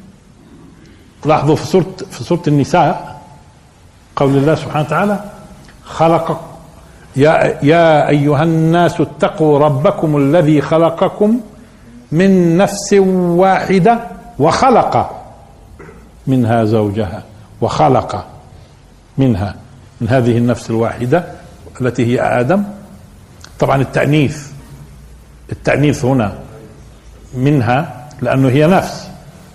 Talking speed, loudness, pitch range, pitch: 85 wpm, -13 LUFS, 125-175 Hz, 150 Hz